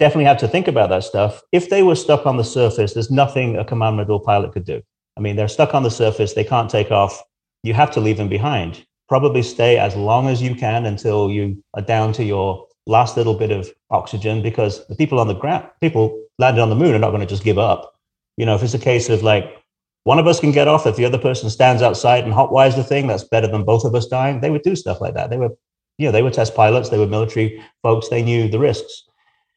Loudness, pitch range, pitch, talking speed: -17 LUFS, 105-130 Hz, 115 Hz, 260 wpm